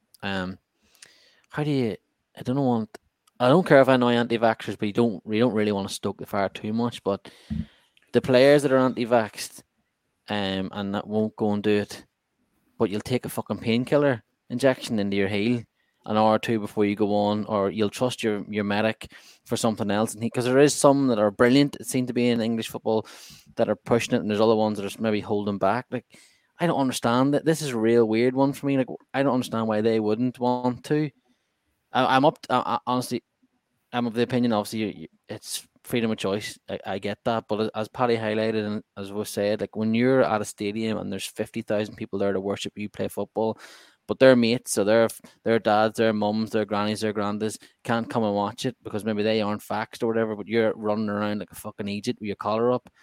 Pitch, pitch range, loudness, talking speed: 110 Hz, 105-125 Hz, -24 LUFS, 225 wpm